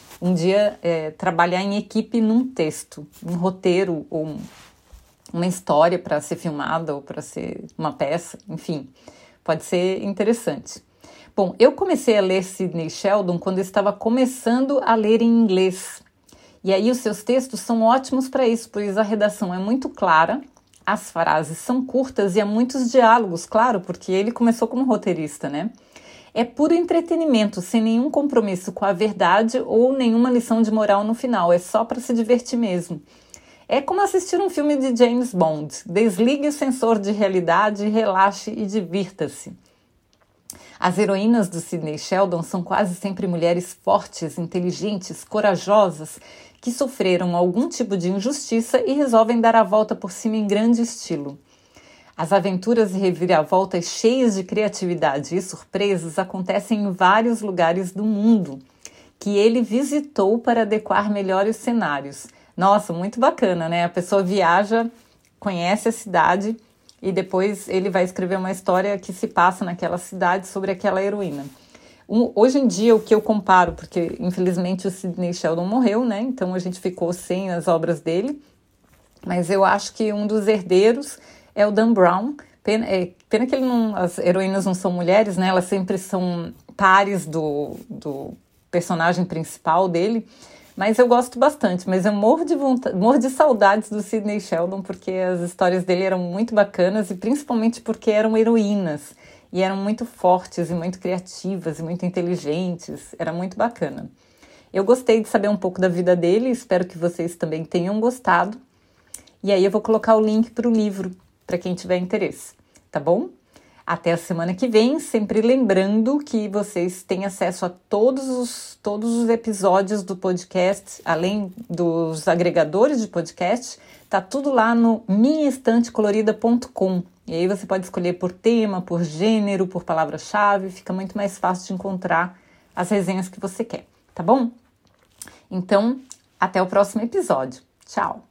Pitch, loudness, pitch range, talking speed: 200 Hz, -20 LUFS, 180-230 Hz, 160 wpm